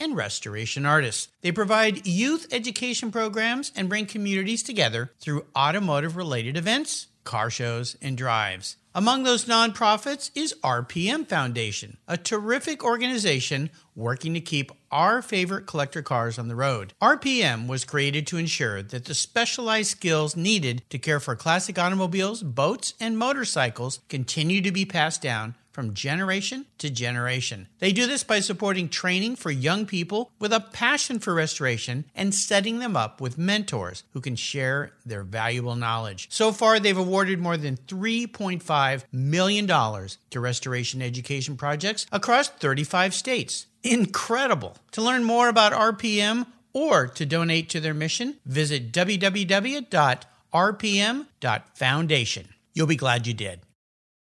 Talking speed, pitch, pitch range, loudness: 140 wpm, 165 Hz, 130-215 Hz, -24 LUFS